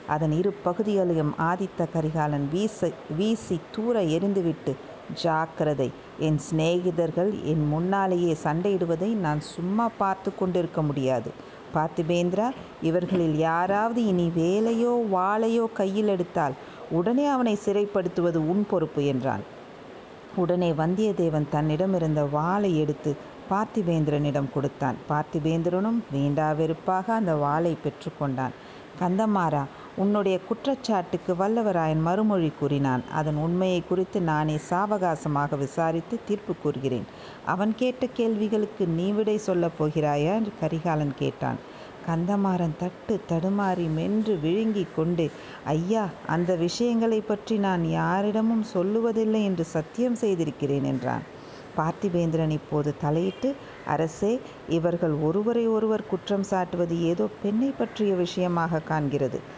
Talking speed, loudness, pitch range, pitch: 100 wpm, -26 LUFS, 155-205 Hz, 175 Hz